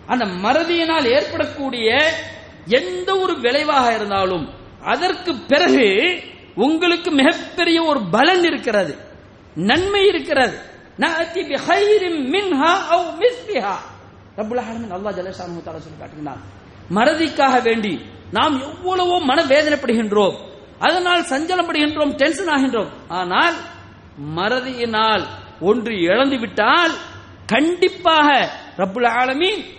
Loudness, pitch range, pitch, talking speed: -17 LUFS, 225-340 Hz, 290 Hz, 95 wpm